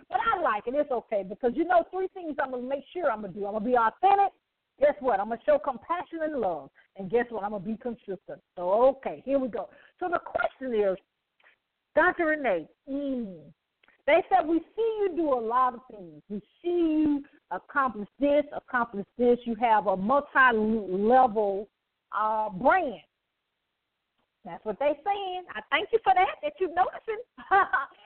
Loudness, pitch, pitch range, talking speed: -27 LUFS, 270 Hz, 220-335 Hz, 180 wpm